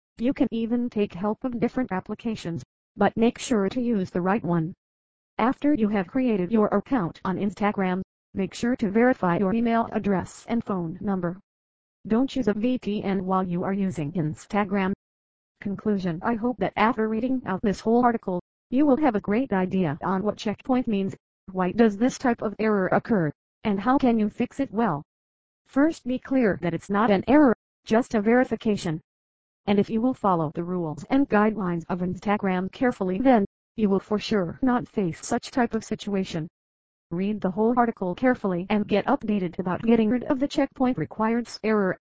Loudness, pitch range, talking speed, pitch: -25 LUFS, 185-235 Hz, 180 wpm, 205 Hz